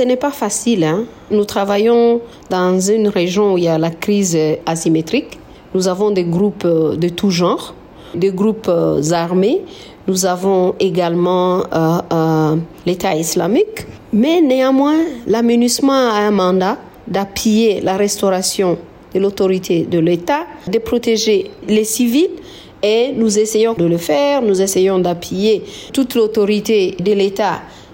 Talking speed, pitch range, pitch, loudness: 135 wpm, 175-225 Hz, 200 Hz, -15 LUFS